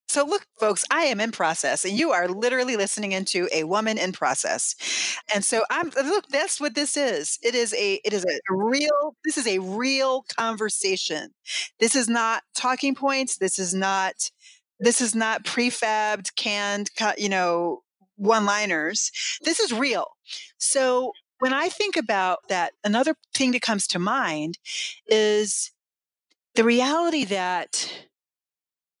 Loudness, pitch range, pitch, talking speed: -24 LUFS, 200-280 Hz, 230 Hz, 150 wpm